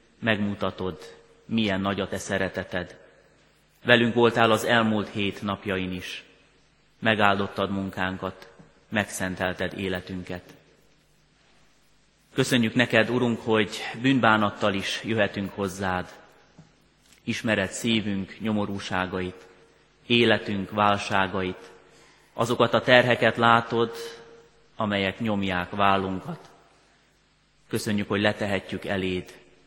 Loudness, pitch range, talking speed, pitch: -25 LUFS, 95-115 Hz, 85 wpm, 100 Hz